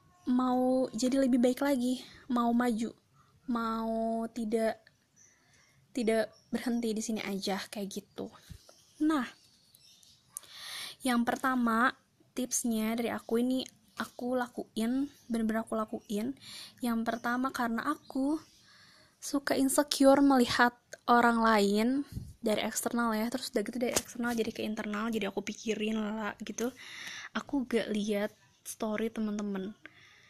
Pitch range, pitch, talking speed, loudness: 220-255 Hz, 235 Hz, 115 wpm, -31 LUFS